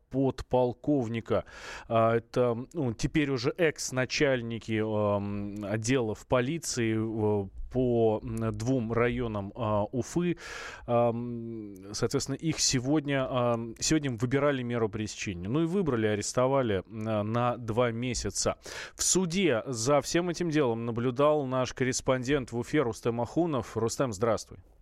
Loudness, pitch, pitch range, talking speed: -29 LUFS, 120 Hz, 110-135 Hz, 100 wpm